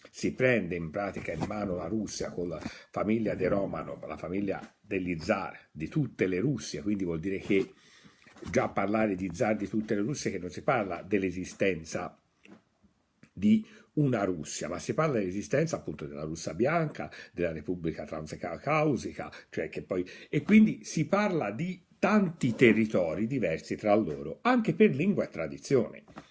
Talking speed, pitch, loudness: 160 wpm, 105 Hz, -30 LUFS